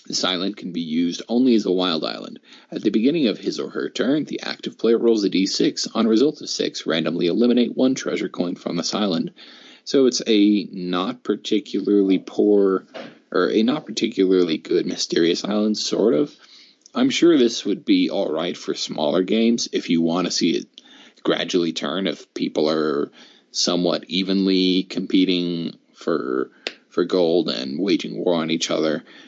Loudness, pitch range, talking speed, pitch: -21 LUFS, 90-125 Hz, 175 wpm, 105 Hz